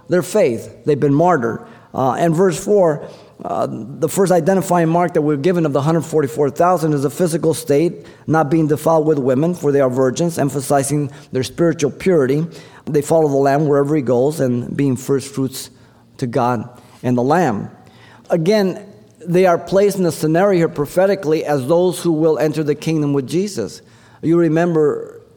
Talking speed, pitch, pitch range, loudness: 170 wpm, 155 Hz, 140-175 Hz, -17 LUFS